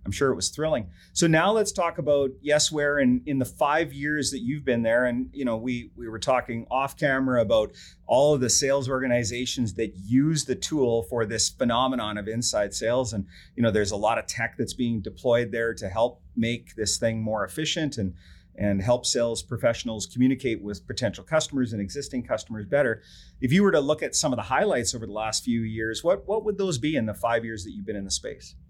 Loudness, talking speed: -25 LUFS, 225 wpm